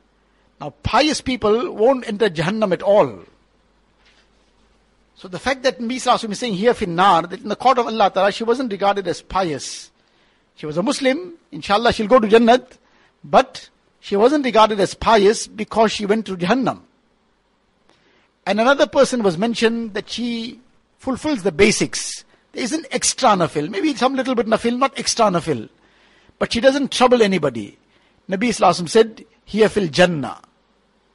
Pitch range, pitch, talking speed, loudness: 200-250 Hz, 225 Hz, 160 wpm, -18 LUFS